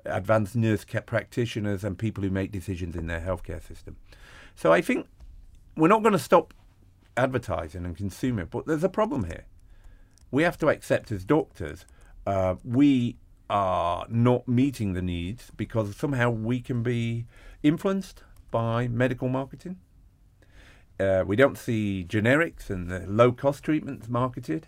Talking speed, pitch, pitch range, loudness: 145 wpm, 105 Hz, 95-125 Hz, -26 LUFS